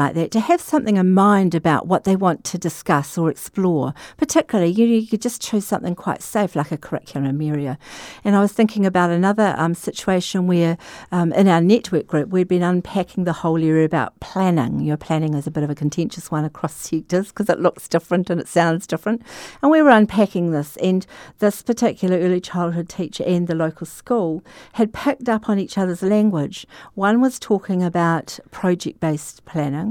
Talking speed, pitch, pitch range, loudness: 195 wpm, 180 Hz, 160-205 Hz, -19 LUFS